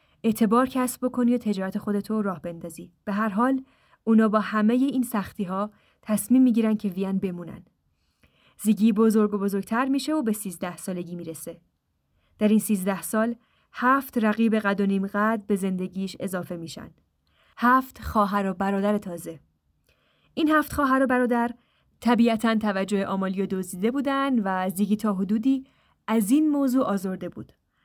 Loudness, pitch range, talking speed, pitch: -24 LUFS, 195-240 Hz, 150 wpm, 210 Hz